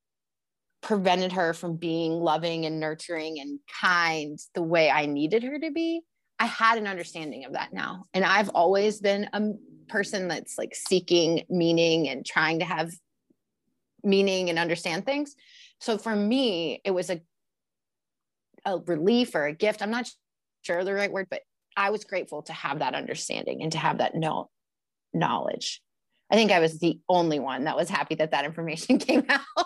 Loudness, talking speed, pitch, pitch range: -26 LUFS, 175 wpm, 180 Hz, 165-215 Hz